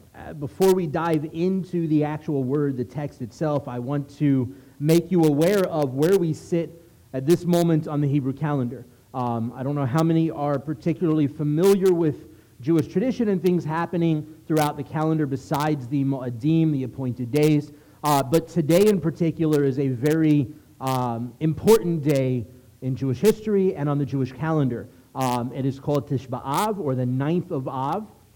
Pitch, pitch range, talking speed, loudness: 150 Hz, 135-165 Hz, 175 wpm, -23 LUFS